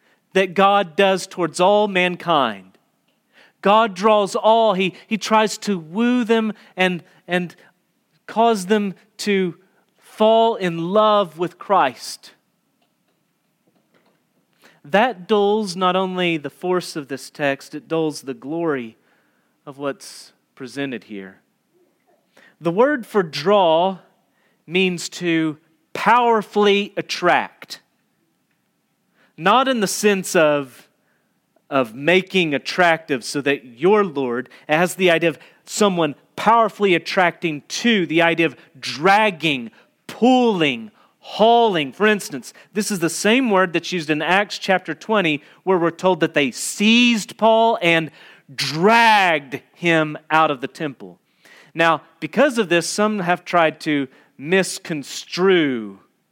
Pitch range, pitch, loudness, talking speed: 155-210 Hz, 180 Hz, -18 LUFS, 120 wpm